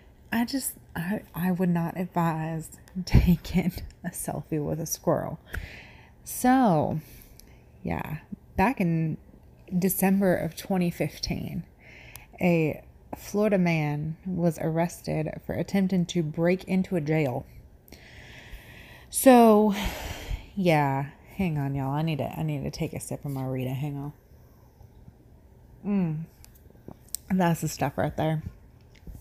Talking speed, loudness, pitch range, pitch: 115 wpm, -27 LUFS, 150-185 Hz, 165 Hz